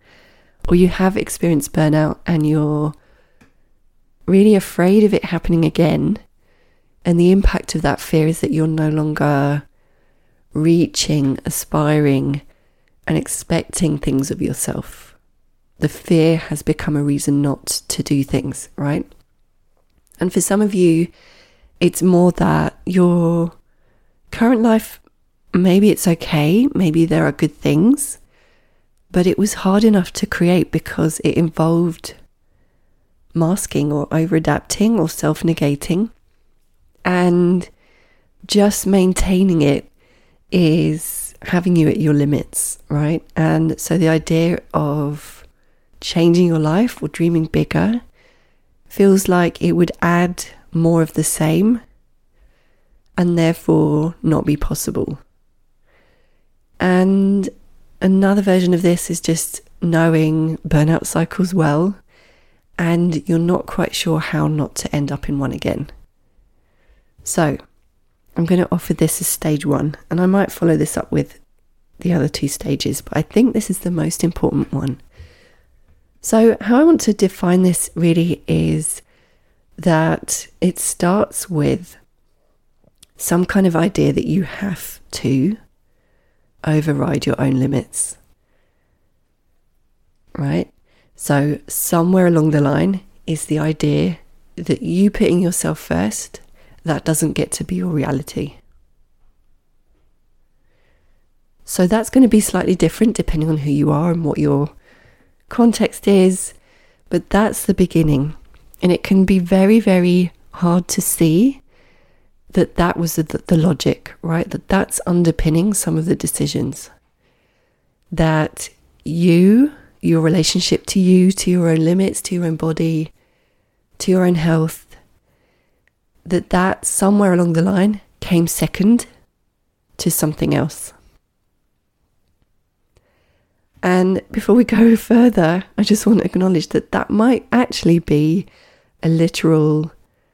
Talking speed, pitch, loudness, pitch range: 130 wpm, 170 Hz, -17 LUFS, 155-185 Hz